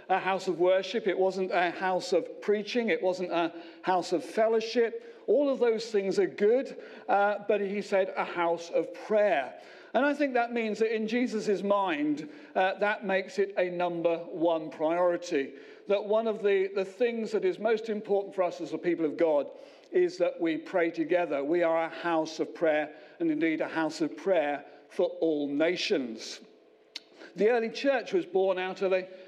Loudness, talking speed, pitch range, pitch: -29 LUFS, 195 wpm, 170-225 Hz, 190 Hz